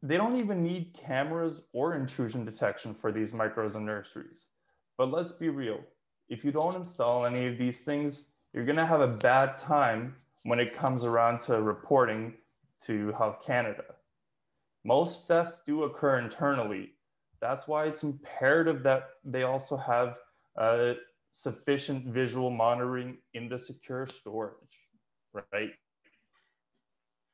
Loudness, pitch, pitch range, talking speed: -30 LUFS, 130 Hz, 120-145 Hz, 135 wpm